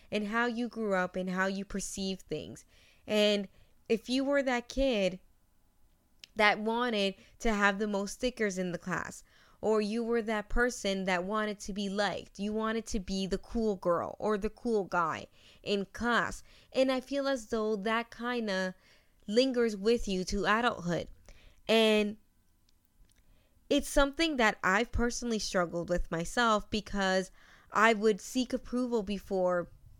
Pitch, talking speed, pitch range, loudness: 210 Hz, 155 wpm, 190-235 Hz, -31 LUFS